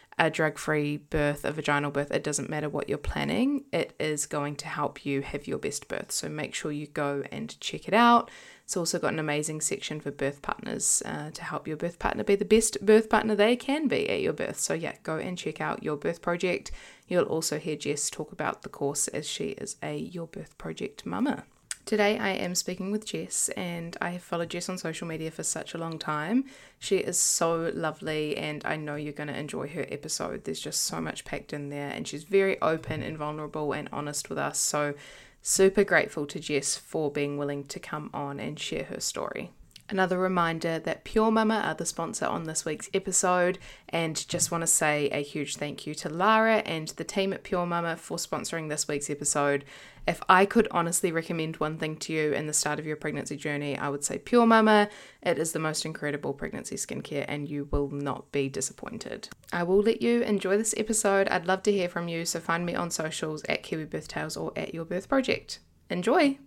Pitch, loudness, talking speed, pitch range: 160 Hz, -28 LUFS, 220 wpm, 150-195 Hz